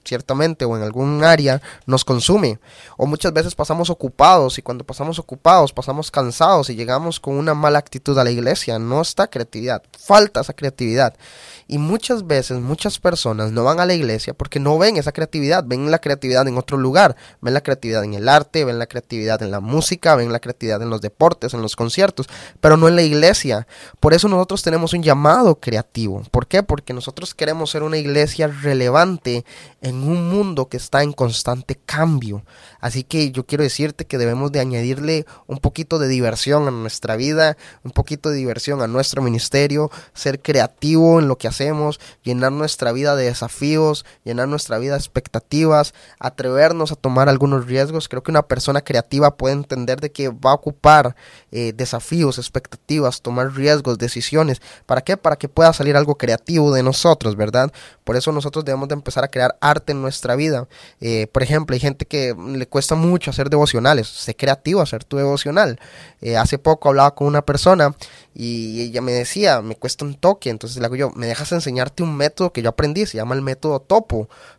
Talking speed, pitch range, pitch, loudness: 190 wpm, 125-155 Hz, 140 Hz, -17 LUFS